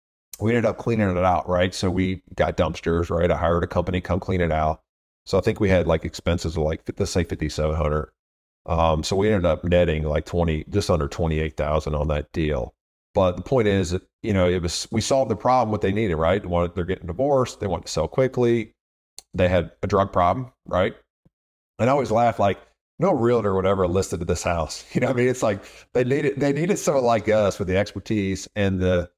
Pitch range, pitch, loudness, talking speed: 85-110 Hz, 90 Hz, -23 LUFS, 230 wpm